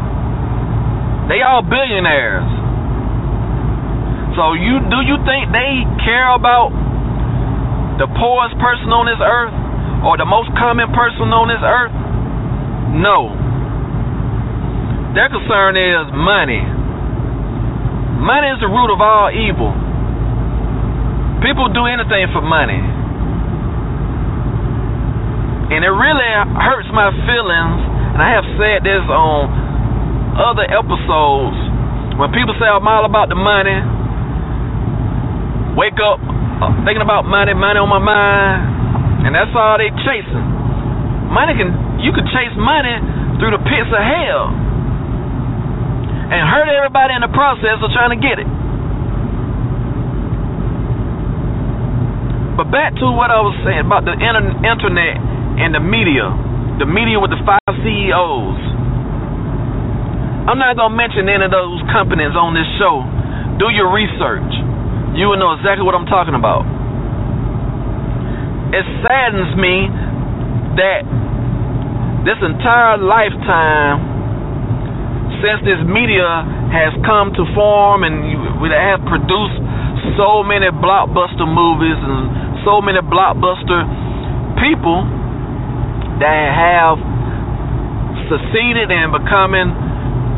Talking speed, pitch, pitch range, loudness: 115 wpm, 130 Hz, 120-185 Hz, -14 LUFS